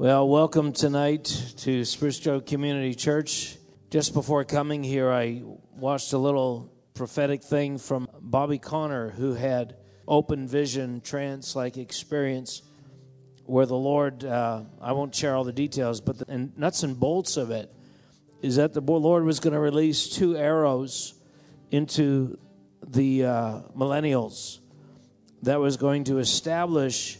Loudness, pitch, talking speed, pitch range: -26 LUFS, 135 Hz, 135 wpm, 130-145 Hz